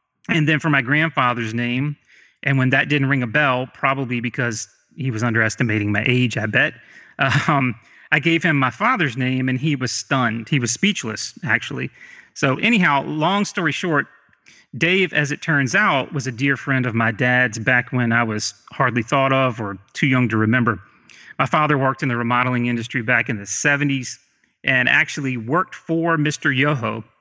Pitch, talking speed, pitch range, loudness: 130 Hz, 185 wpm, 120-145 Hz, -19 LUFS